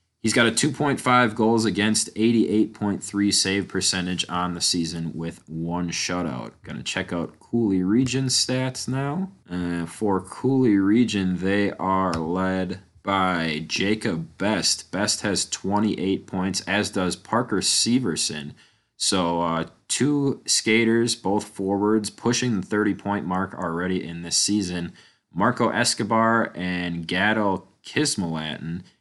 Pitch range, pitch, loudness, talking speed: 90-115 Hz, 100 Hz, -23 LUFS, 125 wpm